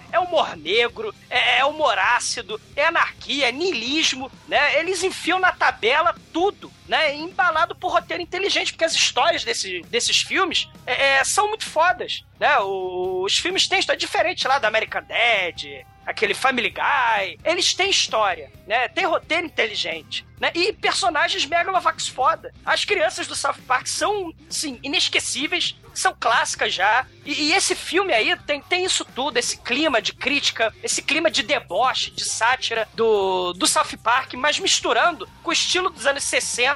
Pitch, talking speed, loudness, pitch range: 325 Hz, 165 wpm, -20 LUFS, 275-365 Hz